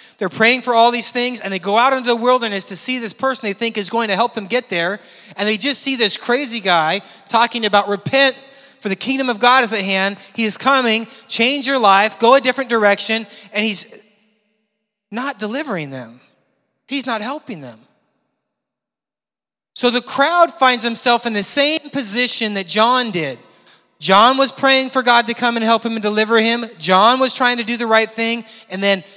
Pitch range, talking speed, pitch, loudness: 205-250 Hz, 200 wpm, 230 Hz, -15 LUFS